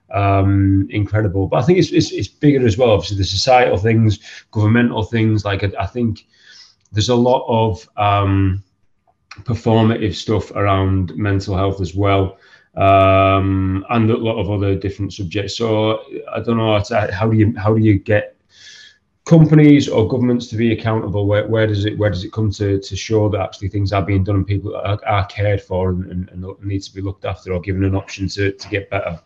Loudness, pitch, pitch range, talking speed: -17 LUFS, 100 Hz, 95-110 Hz, 205 wpm